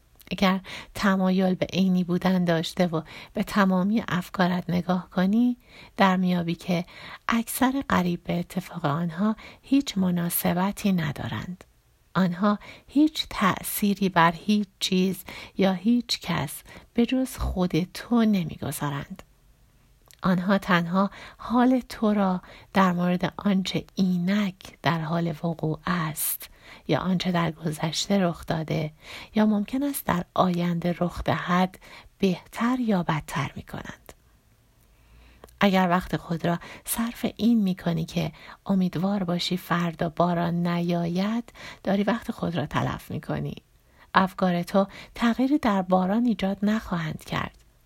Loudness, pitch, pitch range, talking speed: -25 LUFS, 180 Hz, 170-200 Hz, 125 wpm